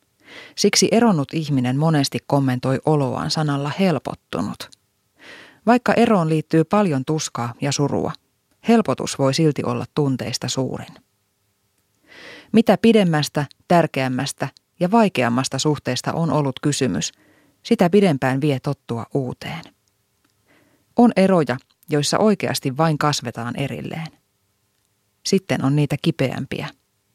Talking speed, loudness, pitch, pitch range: 100 wpm, -20 LUFS, 145 Hz, 130-165 Hz